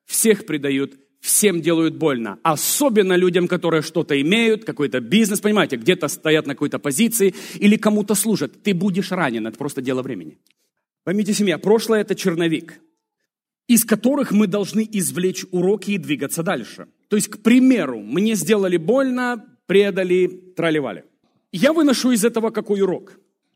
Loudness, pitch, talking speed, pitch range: -19 LUFS, 195 Hz, 145 wpm, 165-215 Hz